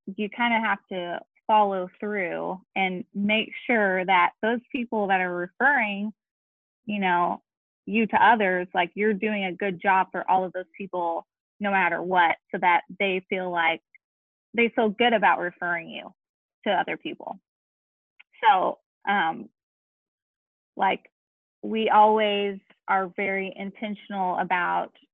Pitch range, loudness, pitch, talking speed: 180-215 Hz, -24 LUFS, 195 Hz, 140 wpm